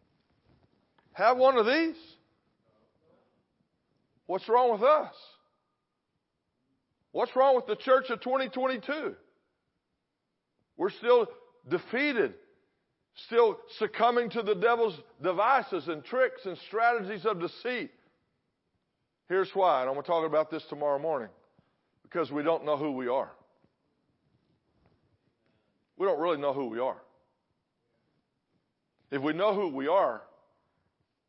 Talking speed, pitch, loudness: 115 wpm, 235 Hz, -28 LUFS